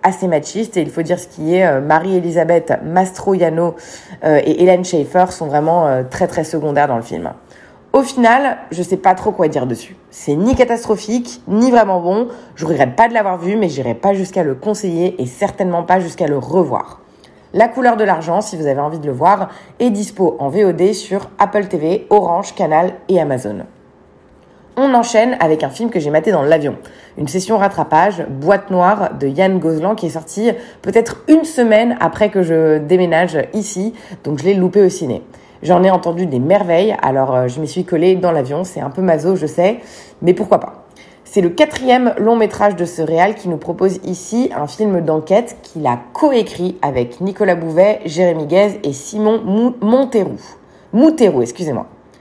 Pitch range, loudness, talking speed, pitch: 160-210 Hz, -15 LUFS, 185 wpm, 185 Hz